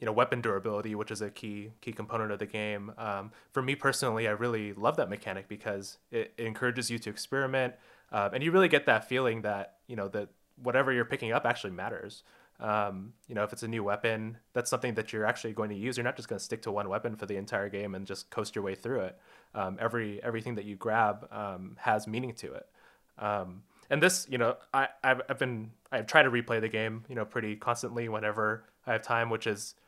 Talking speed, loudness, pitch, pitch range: 235 wpm, -32 LUFS, 110 Hz, 105-120 Hz